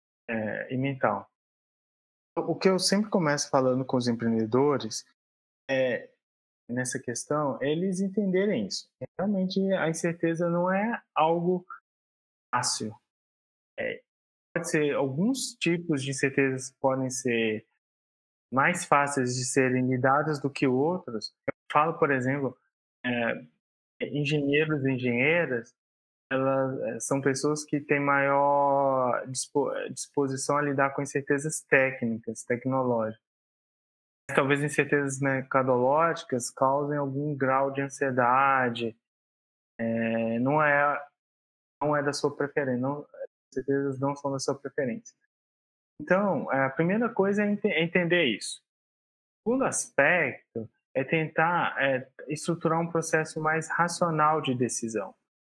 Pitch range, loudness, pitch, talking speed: 130-160 Hz, -27 LUFS, 140 Hz, 115 wpm